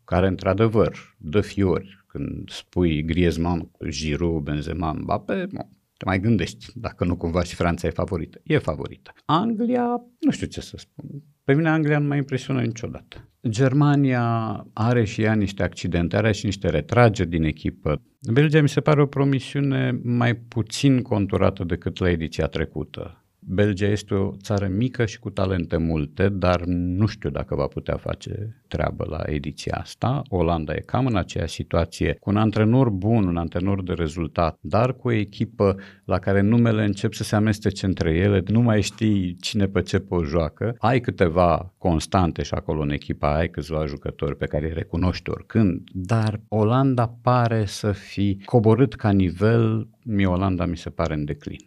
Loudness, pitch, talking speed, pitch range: -23 LUFS, 100 Hz, 170 wpm, 85-115 Hz